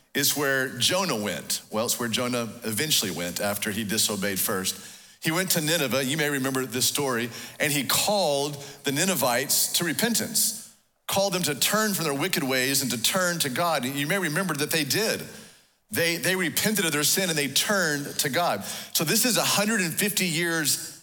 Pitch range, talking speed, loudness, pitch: 130-185 Hz, 190 wpm, -24 LUFS, 145 Hz